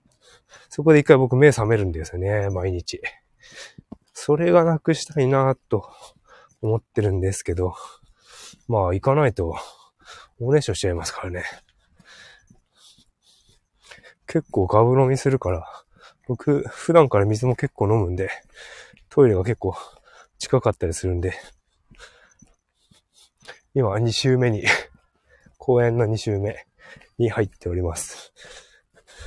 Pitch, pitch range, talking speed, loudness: 115 Hz, 95-135 Hz, 235 characters per minute, -21 LUFS